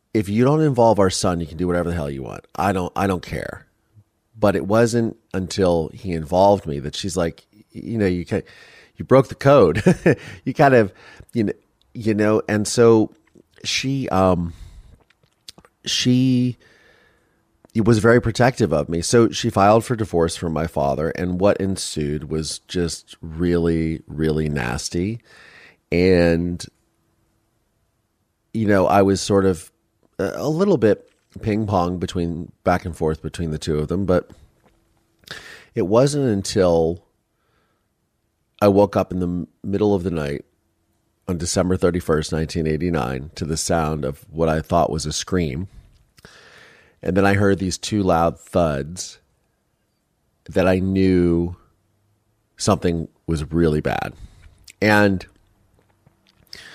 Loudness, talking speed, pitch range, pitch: -20 LUFS, 145 wpm, 85-105 Hz, 95 Hz